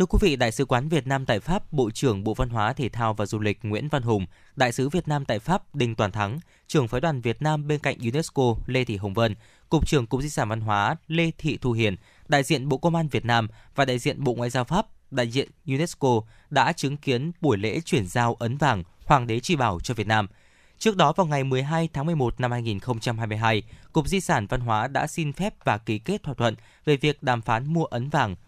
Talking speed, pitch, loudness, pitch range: 245 wpm, 125 Hz, -25 LUFS, 110-150 Hz